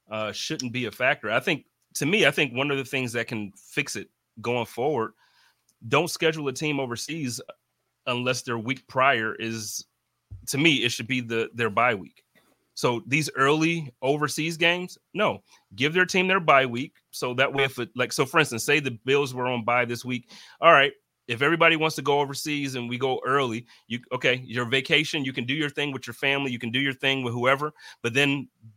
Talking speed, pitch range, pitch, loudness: 215 wpm, 120-150 Hz, 135 Hz, -24 LUFS